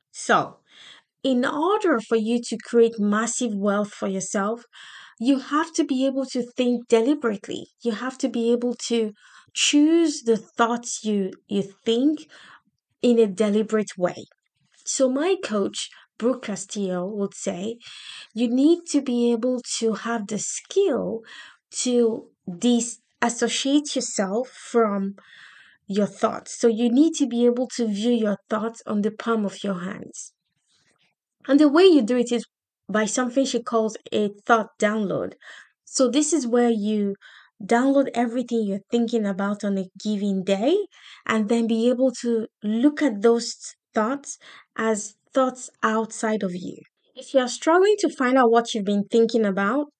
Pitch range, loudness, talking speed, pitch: 215-260 Hz, -23 LUFS, 150 wpm, 235 Hz